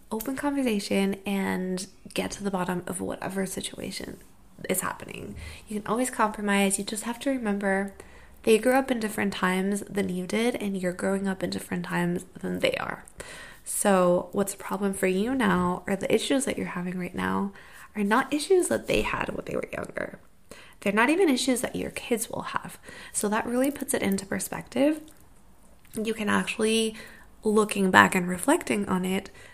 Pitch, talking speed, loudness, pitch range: 205 Hz, 185 wpm, -27 LUFS, 190-240 Hz